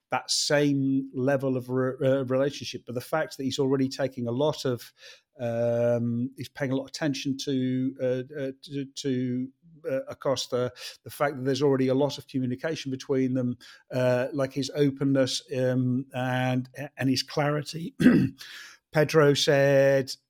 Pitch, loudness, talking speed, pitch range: 135 Hz, -27 LUFS, 155 wpm, 130-140 Hz